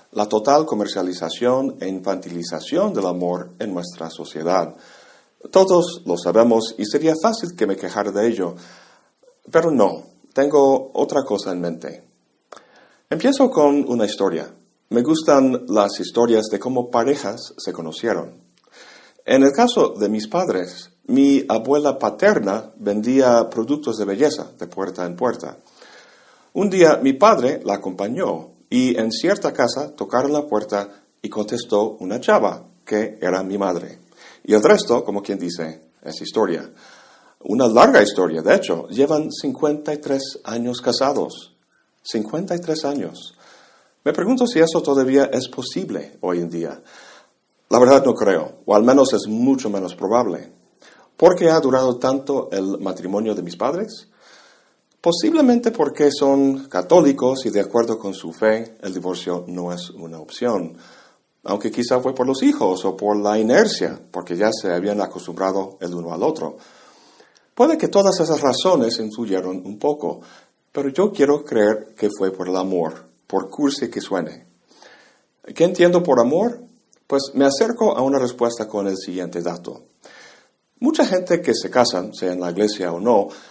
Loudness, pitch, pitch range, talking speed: -19 LUFS, 115 Hz, 95-140 Hz, 150 wpm